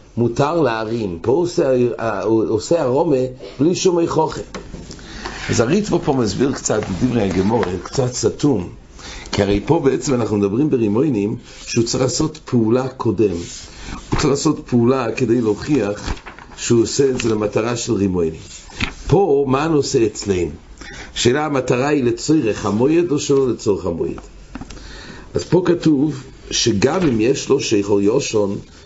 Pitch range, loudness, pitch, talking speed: 105-145 Hz, -18 LUFS, 125 Hz, 135 wpm